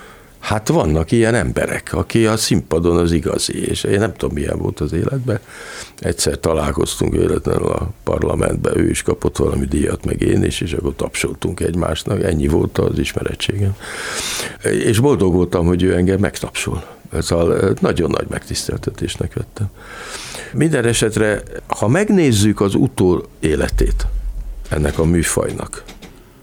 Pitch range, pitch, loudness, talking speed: 85-110 Hz, 95 Hz, -18 LUFS, 140 wpm